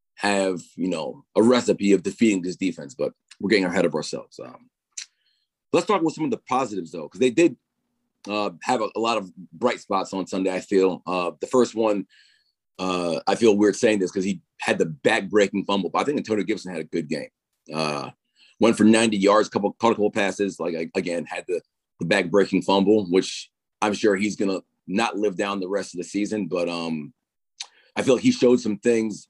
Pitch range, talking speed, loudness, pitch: 90-110 Hz, 215 wpm, -23 LUFS, 100 Hz